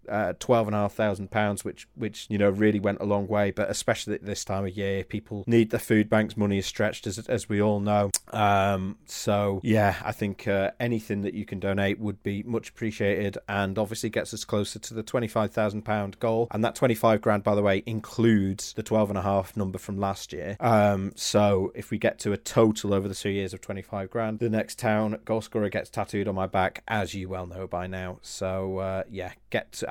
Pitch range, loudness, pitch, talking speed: 100-110 Hz, -27 LUFS, 105 Hz, 215 wpm